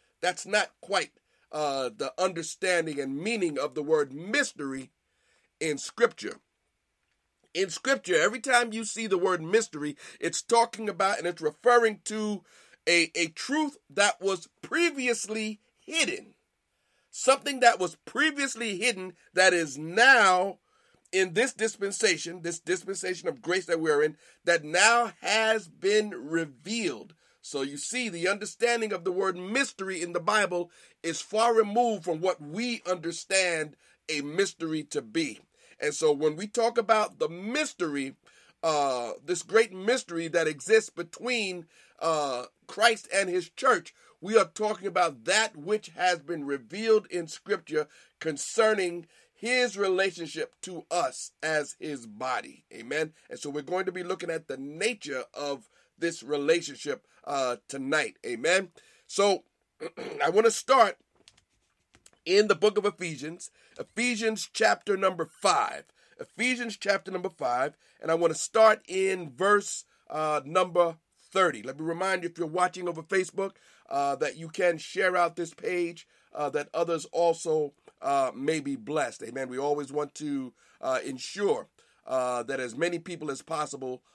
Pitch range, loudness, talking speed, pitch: 160-220 Hz, -28 LUFS, 145 wpm, 185 Hz